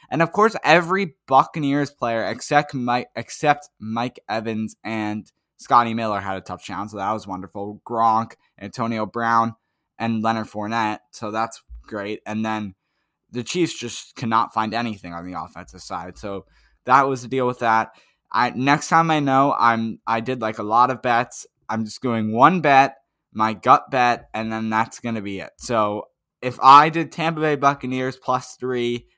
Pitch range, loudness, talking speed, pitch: 110-135 Hz, -21 LUFS, 175 wpm, 115 Hz